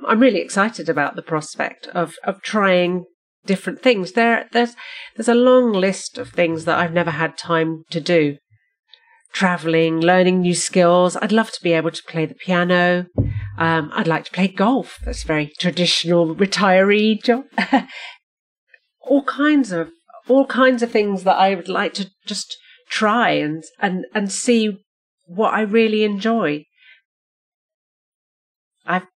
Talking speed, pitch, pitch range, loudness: 150 wpm, 190 Hz, 170-230 Hz, -18 LUFS